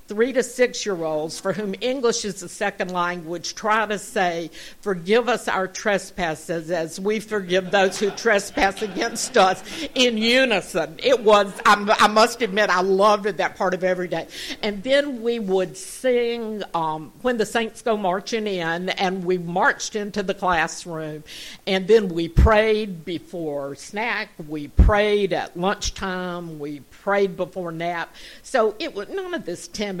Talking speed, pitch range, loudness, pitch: 165 wpm, 175-220 Hz, -22 LUFS, 200 Hz